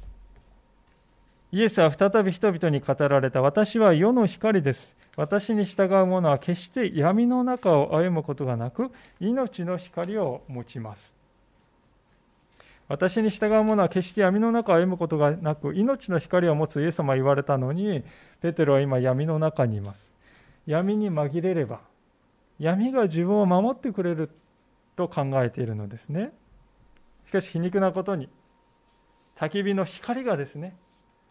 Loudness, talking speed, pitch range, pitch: -24 LUFS, 270 characters per minute, 140-200 Hz, 175 Hz